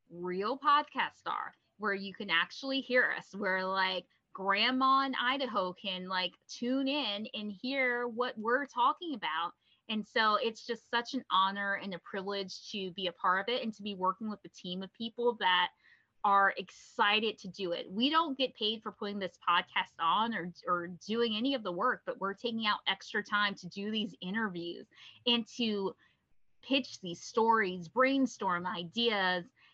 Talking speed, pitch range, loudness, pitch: 180 wpm, 185-245 Hz, -32 LUFS, 210 Hz